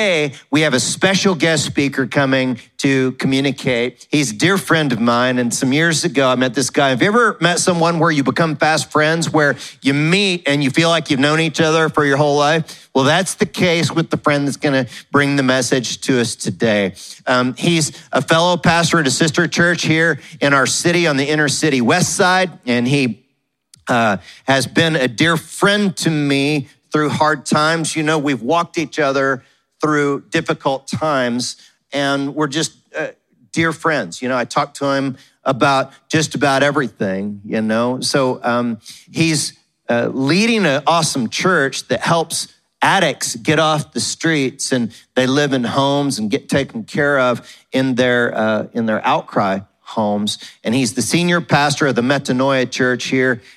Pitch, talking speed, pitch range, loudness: 145 Hz, 185 wpm, 130-160 Hz, -16 LUFS